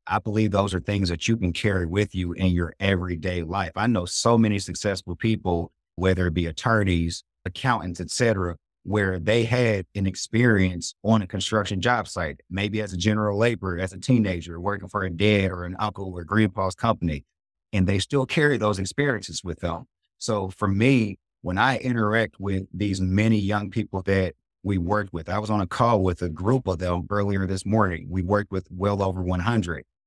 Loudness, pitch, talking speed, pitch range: -24 LUFS, 95 Hz, 195 wpm, 90-110 Hz